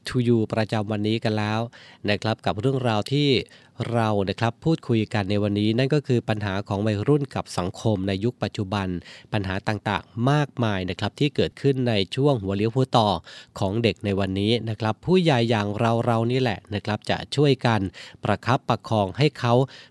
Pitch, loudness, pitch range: 110 Hz, -24 LUFS, 105-125 Hz